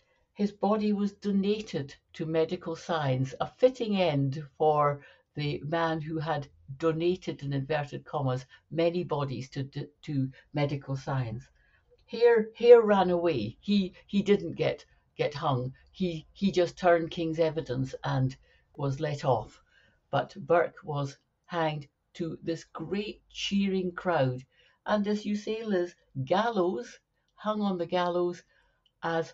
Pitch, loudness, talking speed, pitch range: 165 Hz, -29 LUFS, 135 wpm, 145-190 Hz